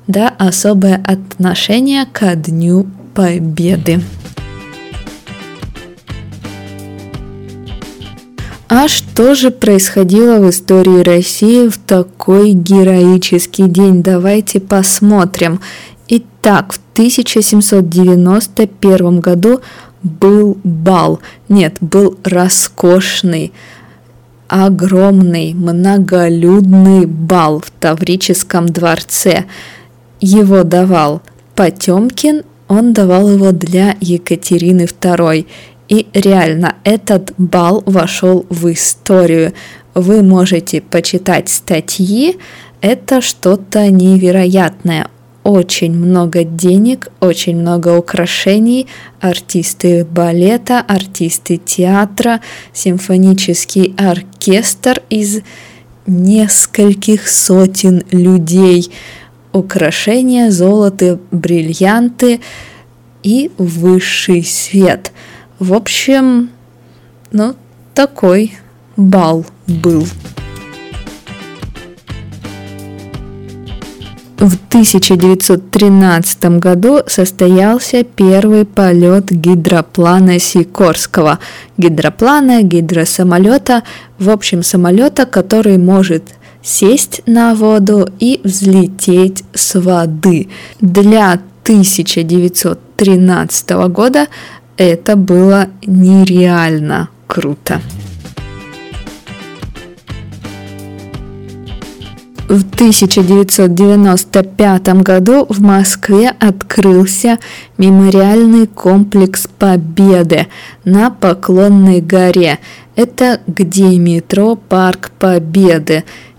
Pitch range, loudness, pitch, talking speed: 175-200 Hz, -9 LUFS, 185 Hz, 70 wpm